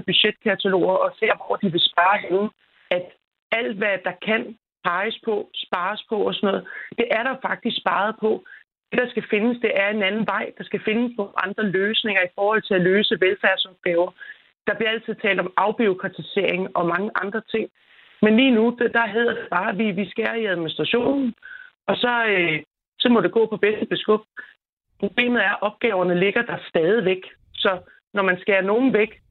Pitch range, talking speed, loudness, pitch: 190-225 Hz, 185 wpm, -21 LUFS, 210 Hz